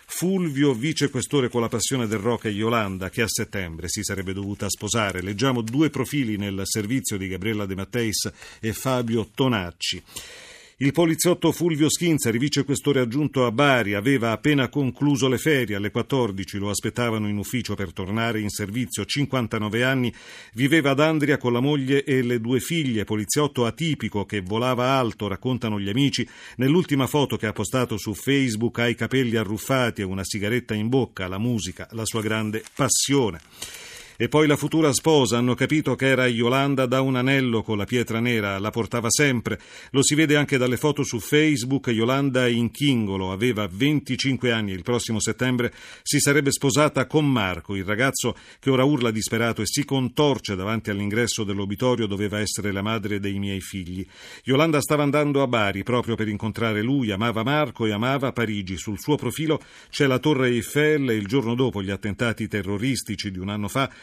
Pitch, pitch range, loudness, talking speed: 120 Hz, 105-135 Hz, -23 LUFS, 175 wpm